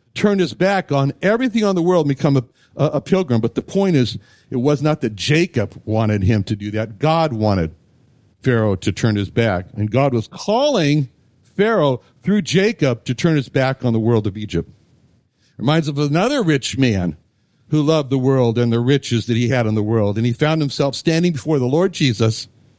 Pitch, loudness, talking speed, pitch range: 130 Hz, -18 LUFS, 205 wpm, 115-155 Hz